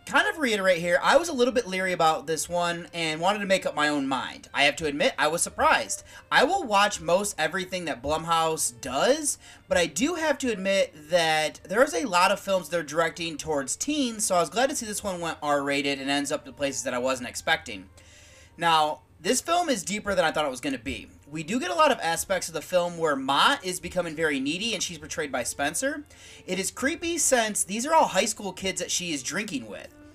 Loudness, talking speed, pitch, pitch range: -25 LUFS, 240 wpm, 180 Hz, 155-235 Hz